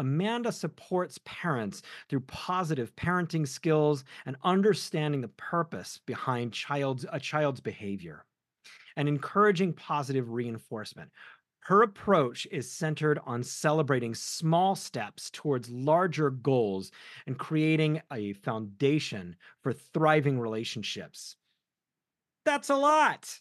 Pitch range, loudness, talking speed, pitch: 130-170 Hz, -29 LUFS, 105 wpm, 150 Hz